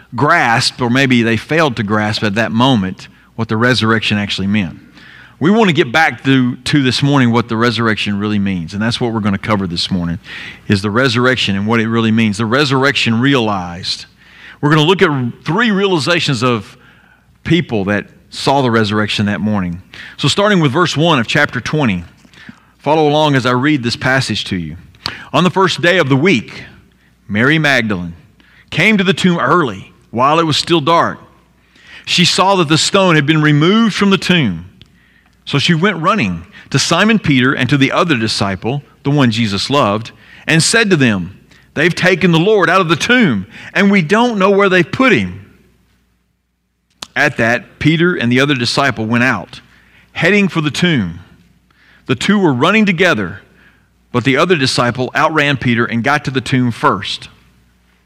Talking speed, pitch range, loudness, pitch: 185 wpm, 105-160 Hz, -13 LUFS, 130 Hz